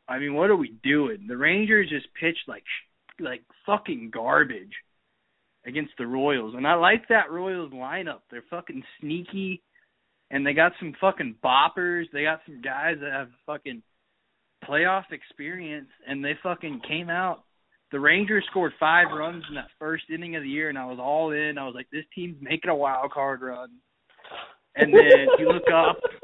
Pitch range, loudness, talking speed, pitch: 145-185 Hz, -23 LUFS, 180 wpm, 160 Hz